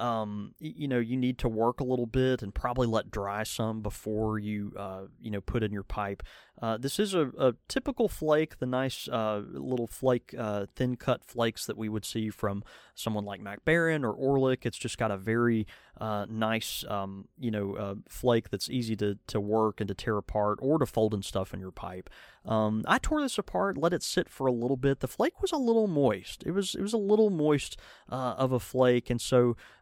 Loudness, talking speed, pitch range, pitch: -30 LUFS, 225 wpm, 105-130 Hz, 115 Hz